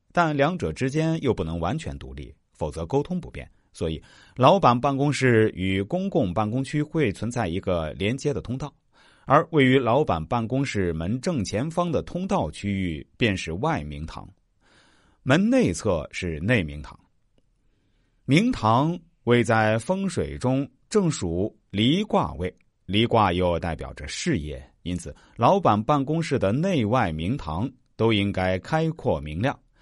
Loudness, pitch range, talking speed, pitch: -24 LUFS, 95-145 Hz, 220 characters per minute, 115 Hz